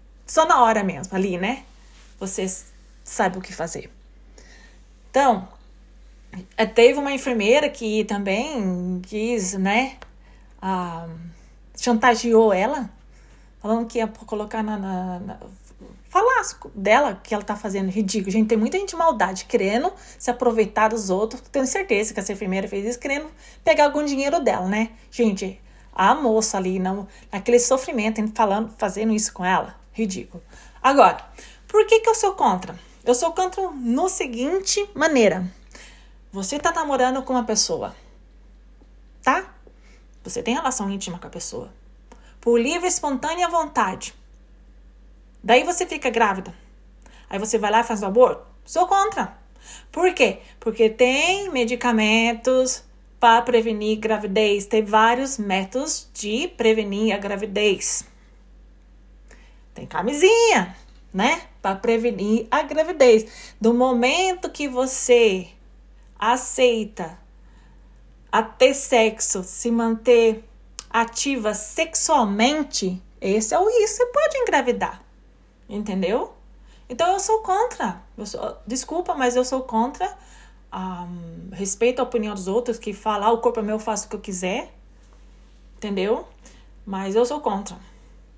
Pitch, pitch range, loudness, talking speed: 230 Hz, 205-265 Hz, -21 LUFS, 130 wpm